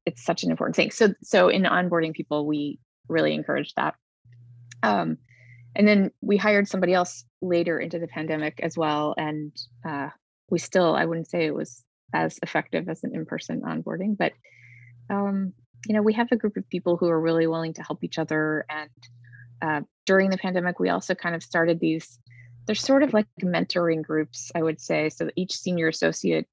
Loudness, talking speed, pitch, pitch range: -25 LUFS, 190 wpm, 160 Hz, 125-180 Hz